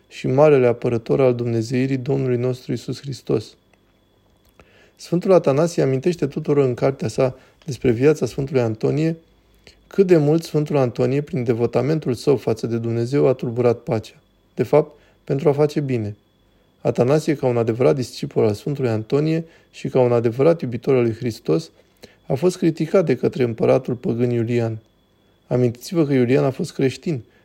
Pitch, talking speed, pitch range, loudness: 130 Hz, 155 wpm, 115-145 Hz, -20 LUFS